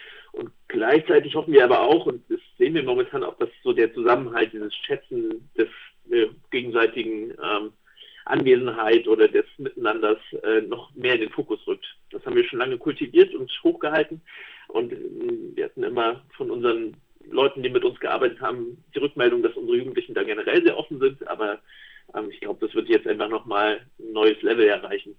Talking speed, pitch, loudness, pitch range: 185 wpm, 380 Hz, -23 LUFS, 360-410 Hz